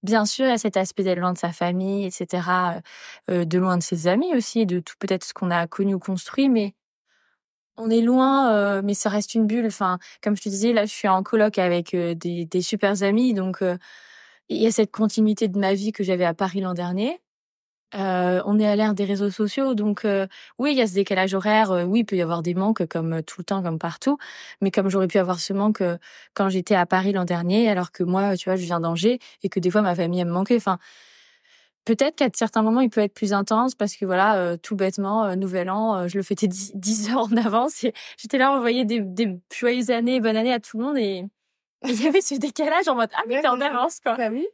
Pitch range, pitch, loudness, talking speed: 185-230 Hz, 205 Hz, -22 LUFS, 255 wpm